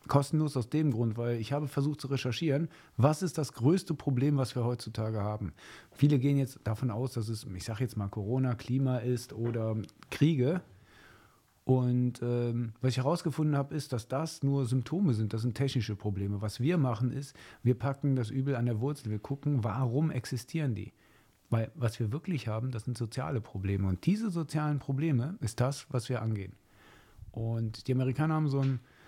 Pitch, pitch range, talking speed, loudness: 125 Hz, 115-140 Hz, 190 wpm, -32 LUFS